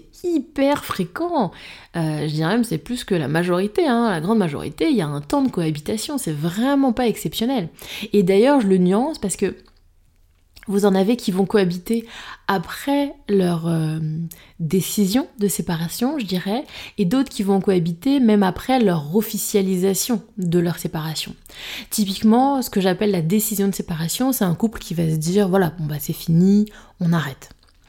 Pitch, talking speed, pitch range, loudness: 195 Hz, 175 wpm, 170-225 Hz, -20 LUFS